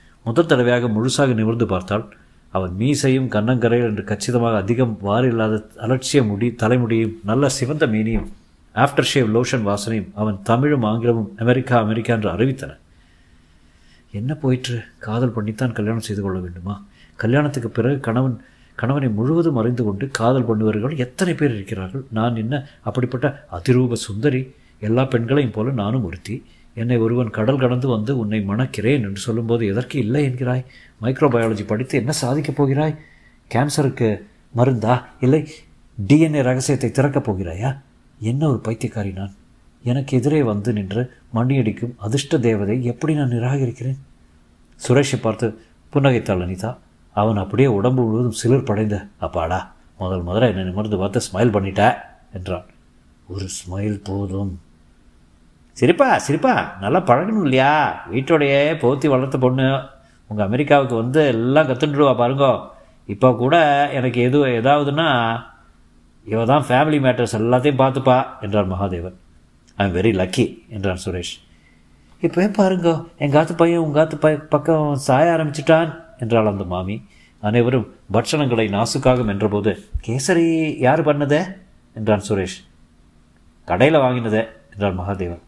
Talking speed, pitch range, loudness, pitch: 125 wpm, 100-135 Hz, -19 LUFS, 120 Hz